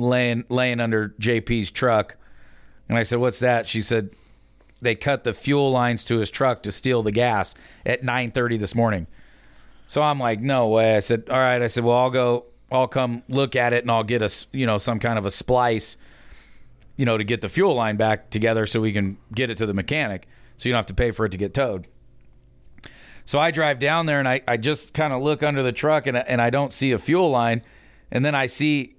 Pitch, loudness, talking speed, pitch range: 120 Hz, -22 LUFS, 235 wpm, 110-130 Hz